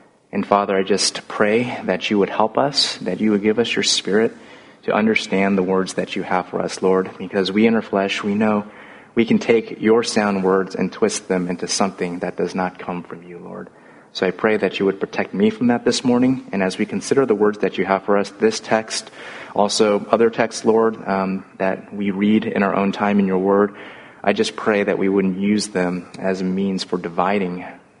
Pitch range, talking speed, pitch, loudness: 95-105 Hz, 225 wpm, 100 Hz, -19 LUFS